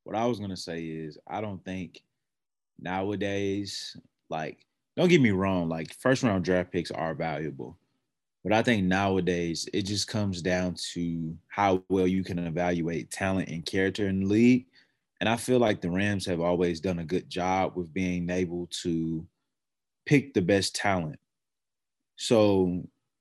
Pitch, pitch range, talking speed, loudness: 95 Hz, 85-100 Hz, 165 wpm, -28 LUFS